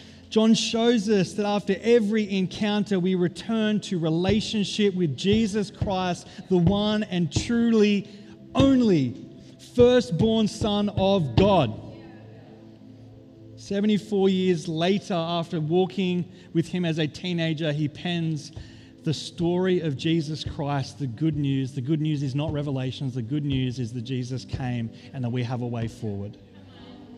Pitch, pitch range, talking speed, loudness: 165 Hz, 130-200 Hz, 140 wpm, -25 LUFS